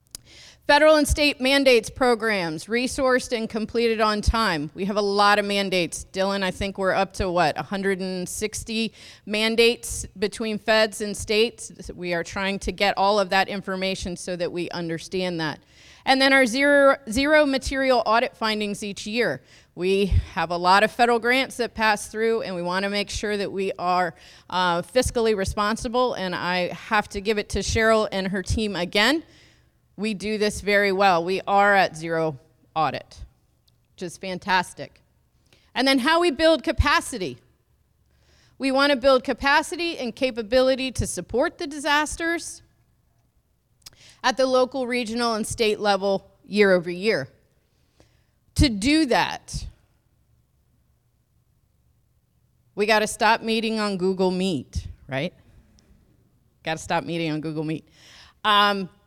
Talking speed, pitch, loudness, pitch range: 150 wpm, 210 Hz, -22 LUFS, 185-240 Hz